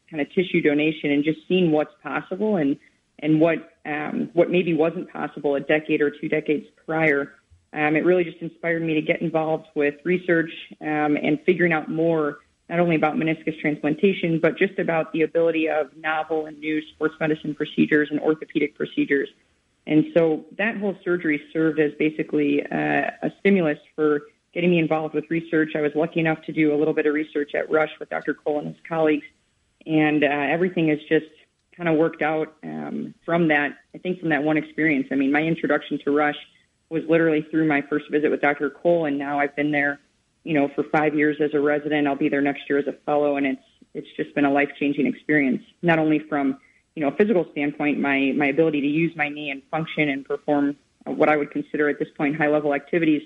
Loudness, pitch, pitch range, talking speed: -23 LUFS, 155 Hz, 145-160 Hz, 210 wpm